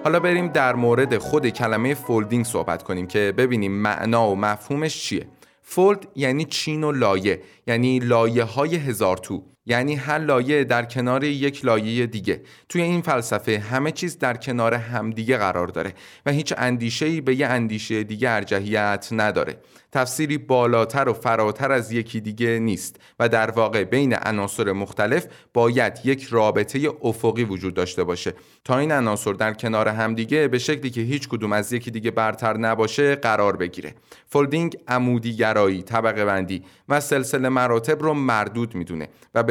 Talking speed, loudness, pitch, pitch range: 155 wpm, -22 LUFS, 120 Hz, 110-140 Hz